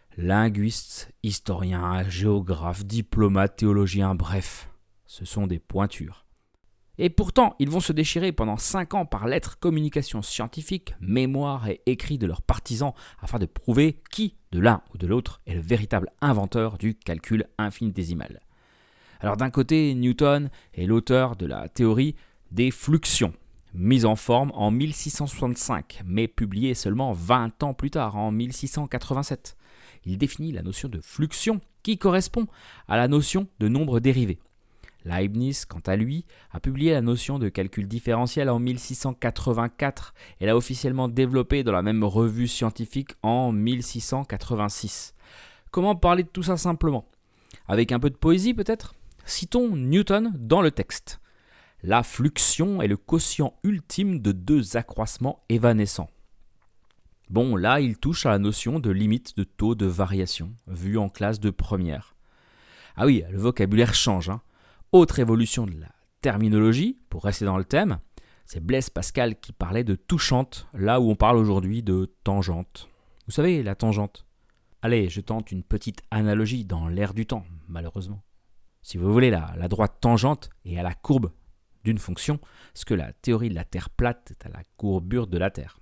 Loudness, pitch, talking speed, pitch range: -24 LUFS, 110 Hz, 160 wpm, 95-135 Hz